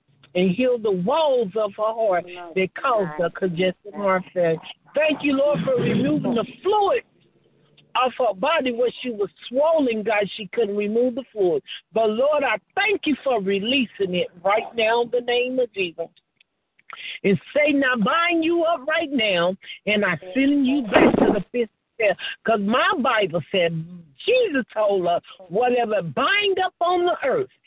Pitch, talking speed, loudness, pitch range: 230 Hz, 170 wpm, -22 LUFS, 190-280 Hz